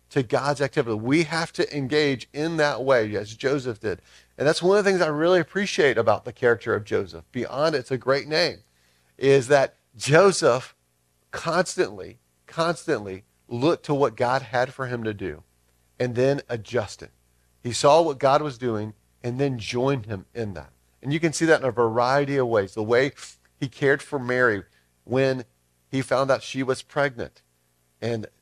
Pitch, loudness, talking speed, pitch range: 125 Hz, -23 LUFS, 180 wpm, 95-140 Hz